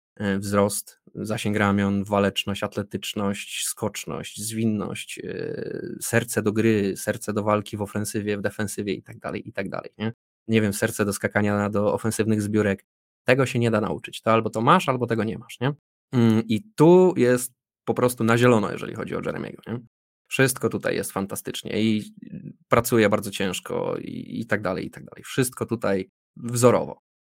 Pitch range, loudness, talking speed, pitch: 105-120 Hz, -24 LUFS, 170 wpm, 110 Hz